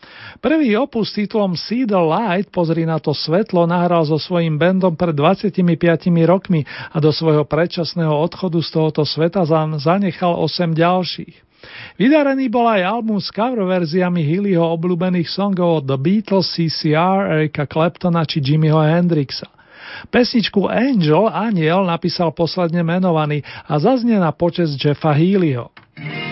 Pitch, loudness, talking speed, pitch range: 175 Hz, -17 LUFS, 135 wpm, 160-190 Hz